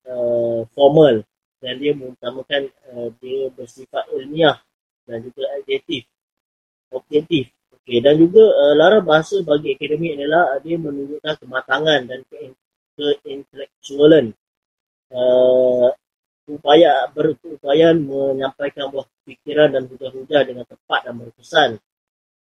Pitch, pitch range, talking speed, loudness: 140 Hz, 130-155 Hz, 110 wpm, -17 LUFS